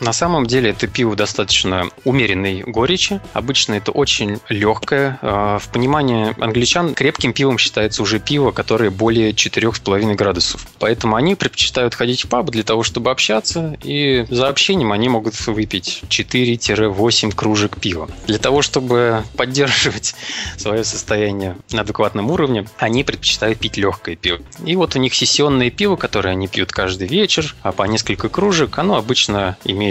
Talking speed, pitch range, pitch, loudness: 150 wpm, 105-130 Hz, 110 Hz, -16 LUFS